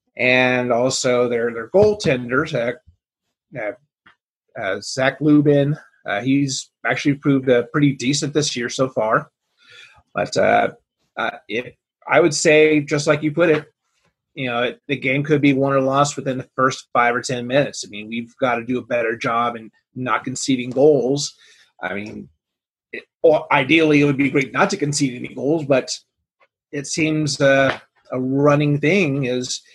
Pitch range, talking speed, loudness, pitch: 125-145 Hz, 170 wpm, -19 LUFS, 135 Hz